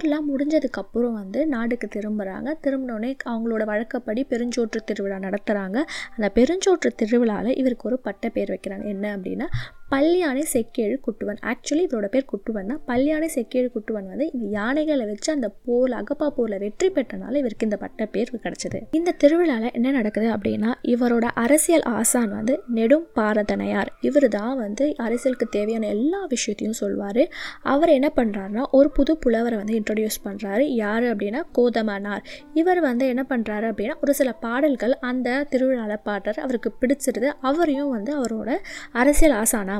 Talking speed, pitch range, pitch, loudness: 145 wpm, 215-280 Hz, 245 Hz, -23 LUFS